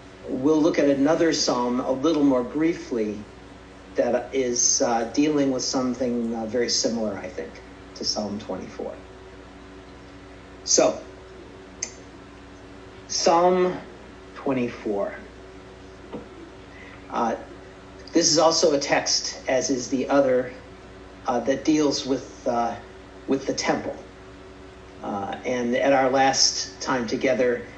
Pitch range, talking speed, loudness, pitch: 95-135 Hz, 115 wpm, -23 LUFS, 105 Hz